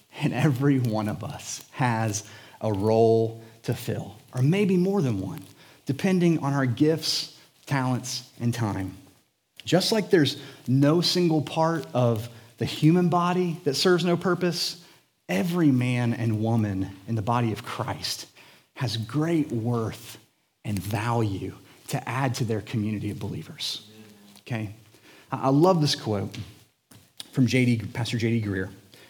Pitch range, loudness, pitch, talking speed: 110-150 Hz, -25 LUFS, 120 Hz, 140 wpm